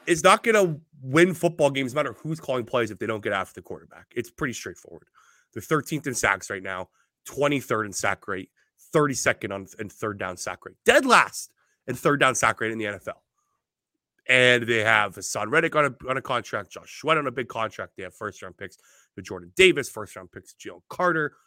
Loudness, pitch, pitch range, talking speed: -23 LUFS, 130 Hz, 110-155 Hz, 215 wpm